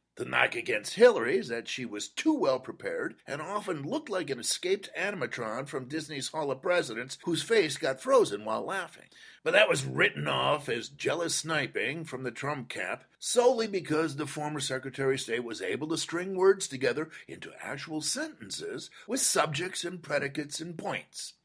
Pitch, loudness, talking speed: 165 Hz, -30 LUFS, 175 wpm